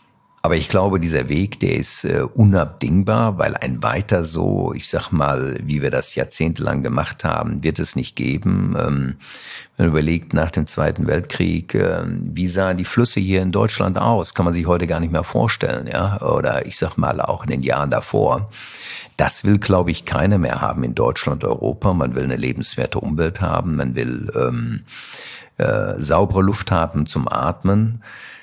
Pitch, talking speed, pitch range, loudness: 90 Hz, 180 wpm, 75-100 Hz, -19 LUFS